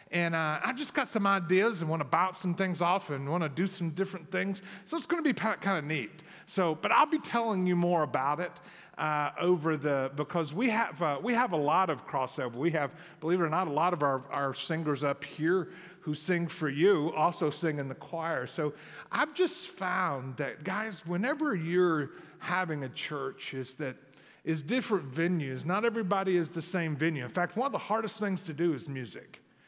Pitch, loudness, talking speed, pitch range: 175 Hz, -31 LUFS, 215 wpm, 155-195 Hz